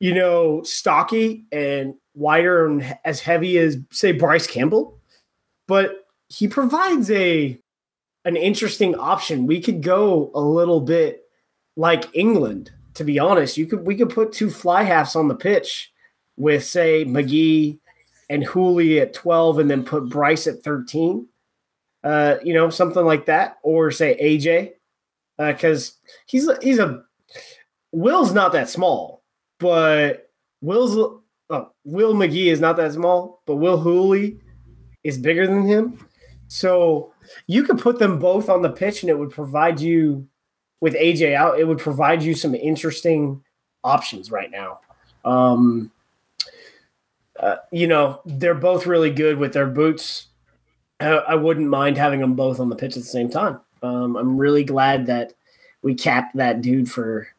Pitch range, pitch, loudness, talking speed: 145-180 Hz, 160 Hz, -19 LUFS, 155 wpm